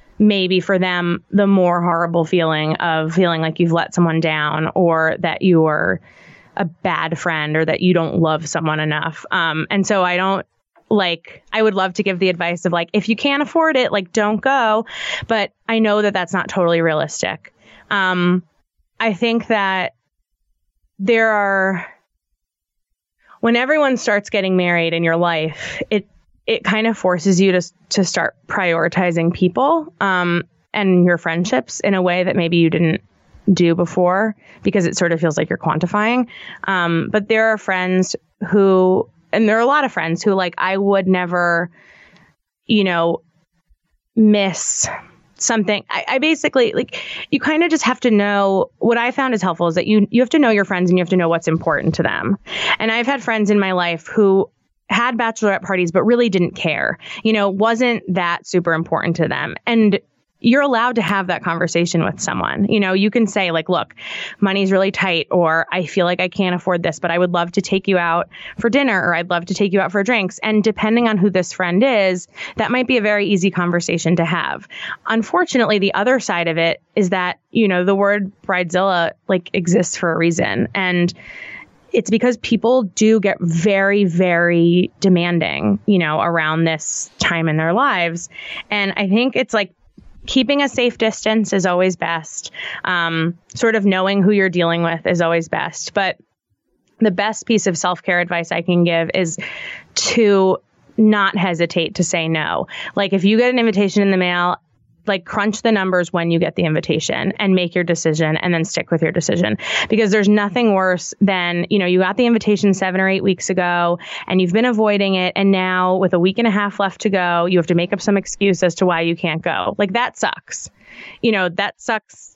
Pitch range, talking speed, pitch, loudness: 170-210 Hz, 195 wpm, 185 Hz, -17 LUFS